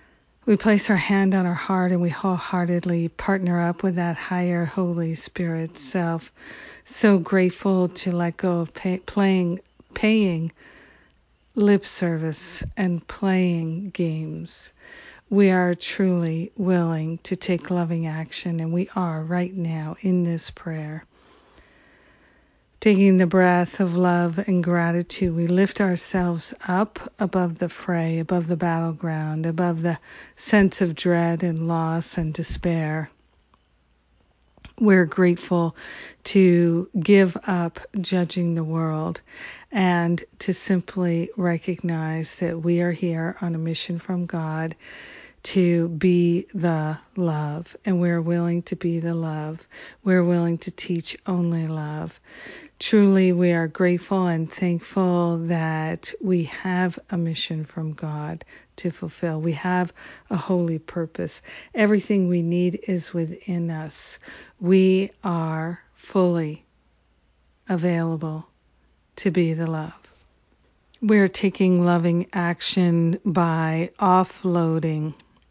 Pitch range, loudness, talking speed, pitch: 165-185 Hz, -23 LUFS, 120 wpm, 175 Hz